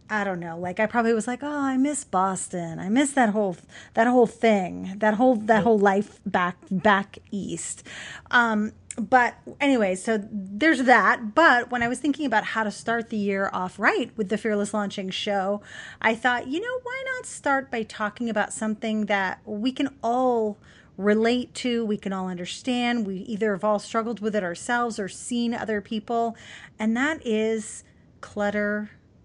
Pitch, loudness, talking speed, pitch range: 220 Hz, -24 LUFS, 180 wpm, 205-245 Hz